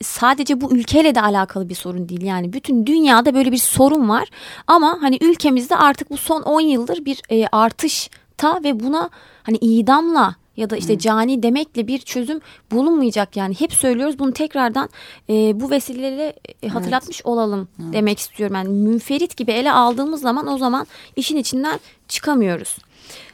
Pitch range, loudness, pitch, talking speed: 220-295 Hz, -18 LUFS, 255 Hz, 150 wpm